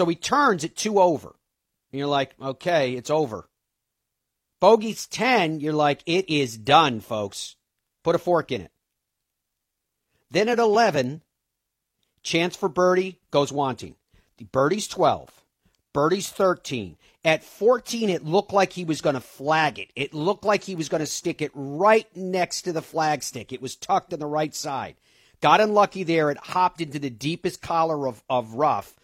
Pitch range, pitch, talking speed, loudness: 140-185 Hz, 160 Hz, 165 wpm, -23 LUFS